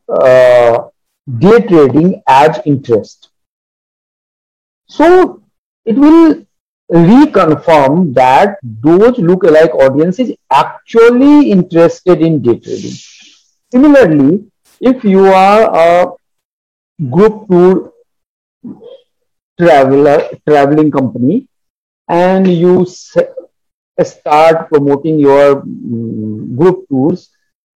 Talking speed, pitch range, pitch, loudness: 80 wpm, 145-220 Hz, 175 Hz, -8 LUFS